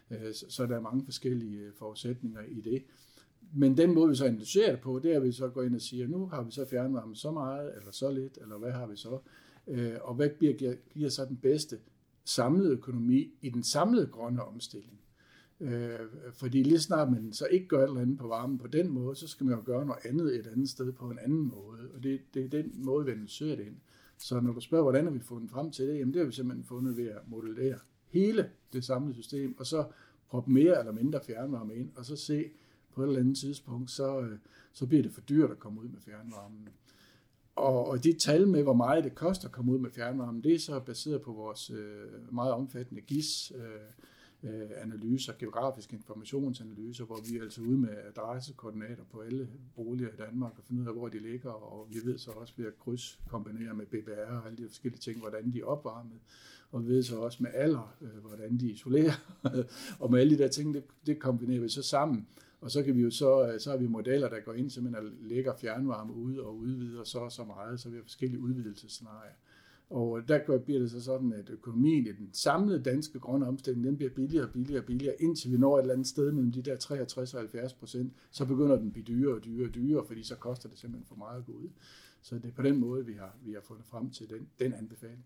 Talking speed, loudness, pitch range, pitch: 235 wpm, -32 LUFS, 115-135 Hz, 125 Hz